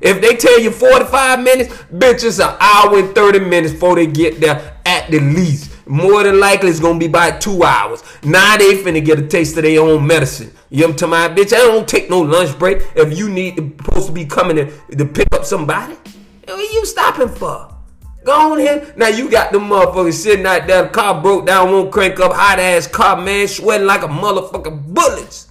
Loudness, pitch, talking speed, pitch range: -12 LUFS, 190 Hz, 220 wpm, 165-220 Hz